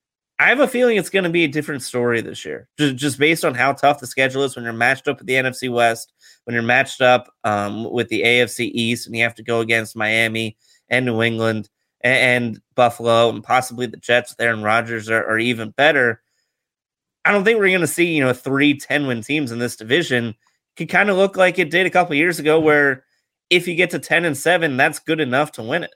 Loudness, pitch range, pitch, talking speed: -18 LUFS, 115-155 Hz, 125 Hz, 240 wpm